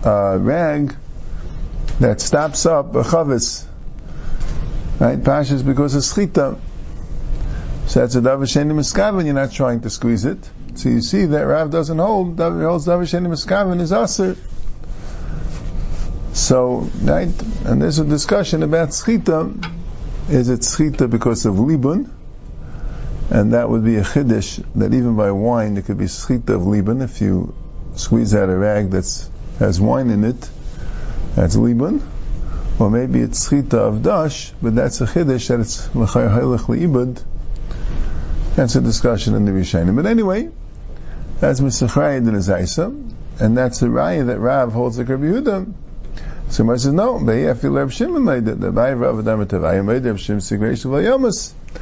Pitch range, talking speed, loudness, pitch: 105-155 Hz, 155 wpm, -17 LUFS, 125 Hz